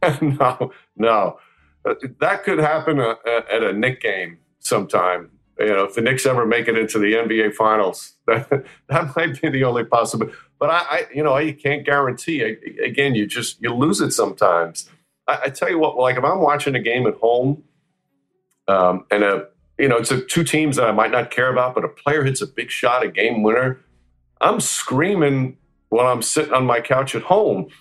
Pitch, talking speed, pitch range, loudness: 130 Hz, 205 wpm, 115-150 Hz, -19 LUFS